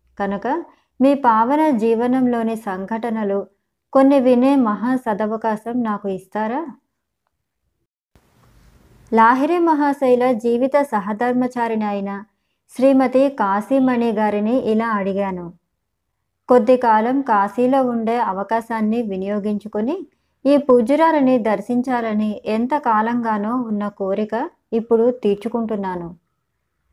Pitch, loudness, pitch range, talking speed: 230 Hz, -18 LUFS, 210-255 Hz, 80 wpm